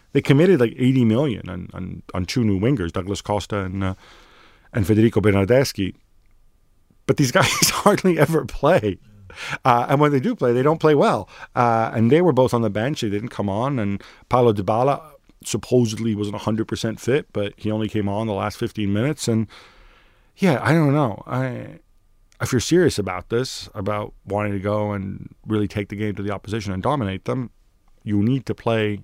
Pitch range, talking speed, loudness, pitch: 100-125 Hz, 195 wpm, -21 LUFS, 110 Hz